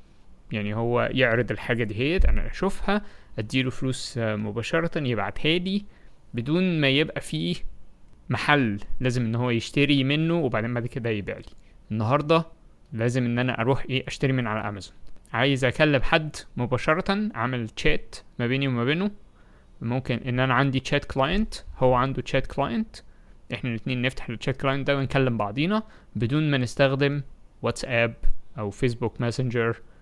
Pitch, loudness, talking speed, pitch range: 130 Hz, -25 LUFS, 145 wpm, 115-145 Hz